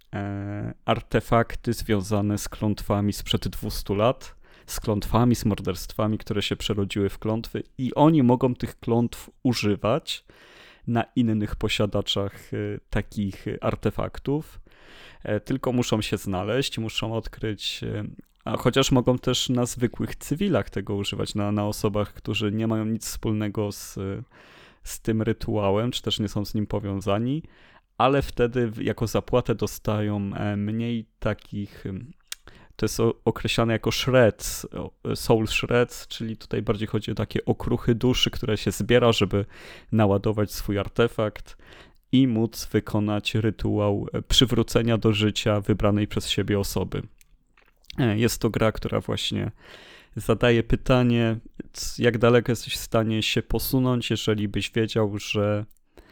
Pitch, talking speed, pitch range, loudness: 110 Hz, 125 wpm, 105-120 Hz, -25 LUFS